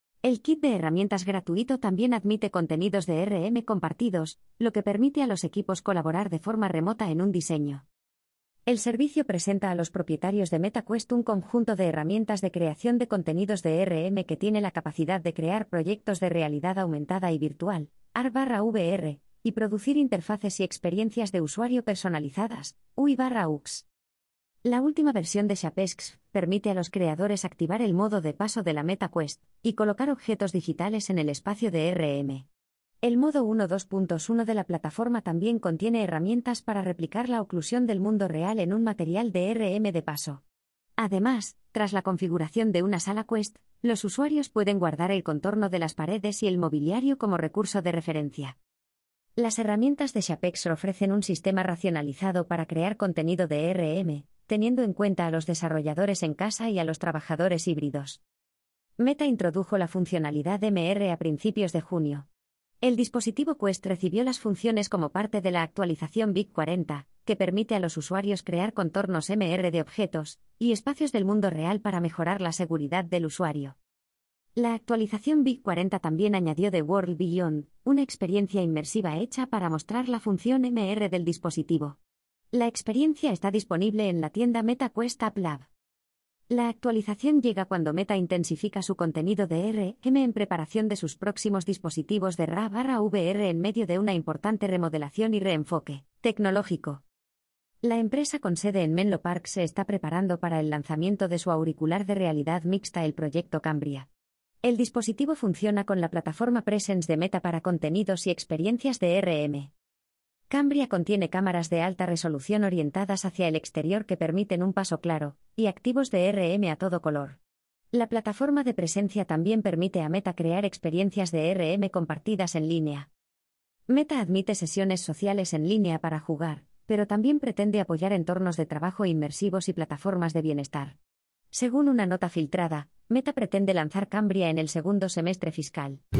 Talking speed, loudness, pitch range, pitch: 165 wpm, -28 LUFS, 165-215 Hz, 190 Hz